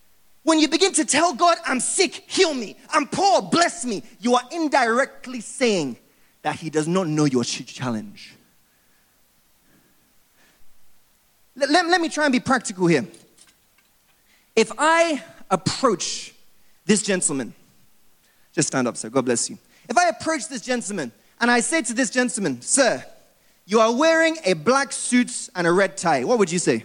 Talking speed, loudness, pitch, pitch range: 160 wpm, -21 LUFS, 245 Hz, 185-310 Hz